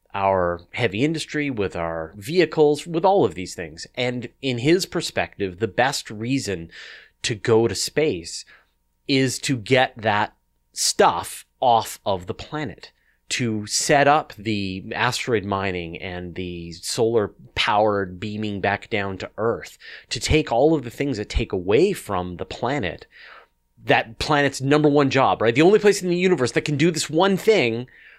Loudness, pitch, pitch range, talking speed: -22 LUFS, 115 Hz, 95-145 Hz, 160 wpm